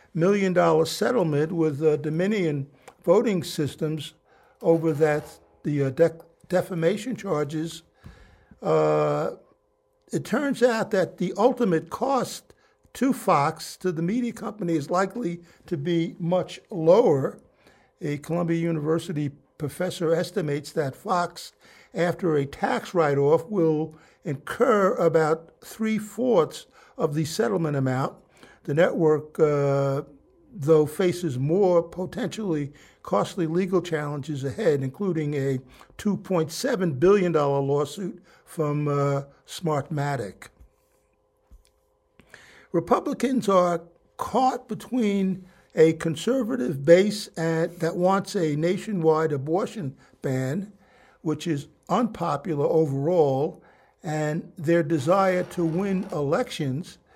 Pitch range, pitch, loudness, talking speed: 155-190 Hz, 170 Hz, -25 LUFS, 100 wpm